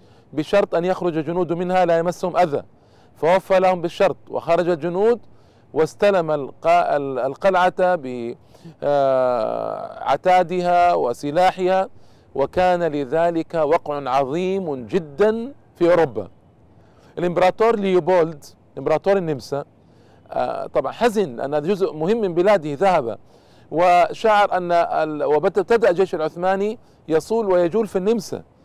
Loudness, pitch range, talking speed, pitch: -20 LUFS, 145-190 Hz, 95 wpm, 175 Hz